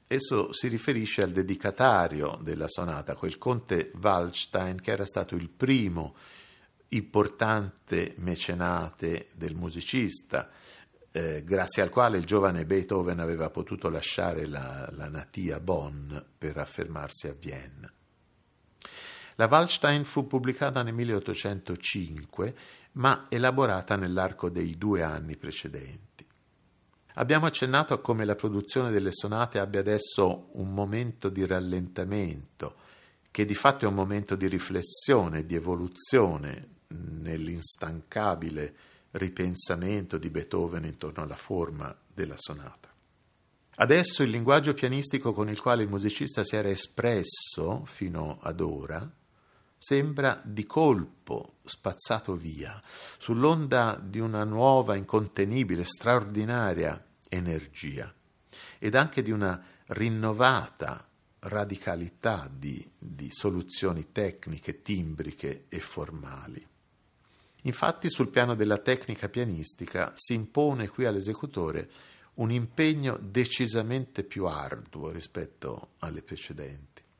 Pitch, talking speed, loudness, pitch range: 100 Hz, 110 wpm, -29 LUFS, 90-120 Hz